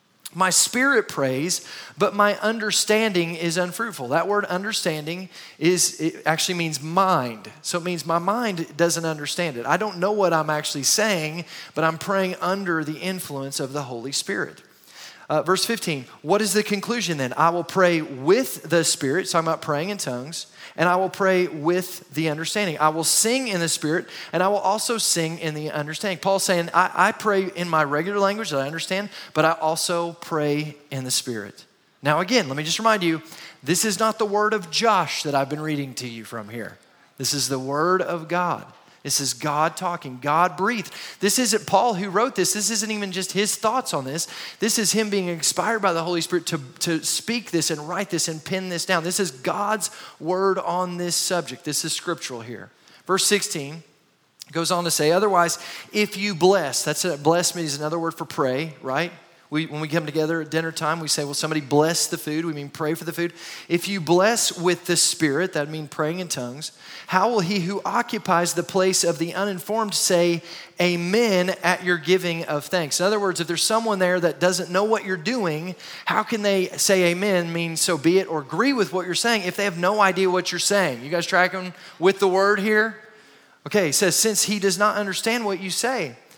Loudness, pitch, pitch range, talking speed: -22 LUFS, 175 Hz, 160-195 Hz, 210 wpm